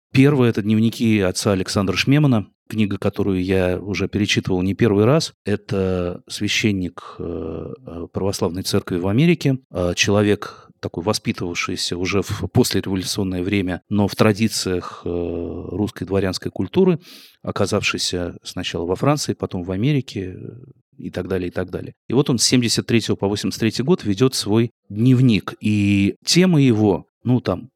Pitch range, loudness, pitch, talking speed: 95-120 Hz, -20 LUFS, 105 Hz, 135 wpm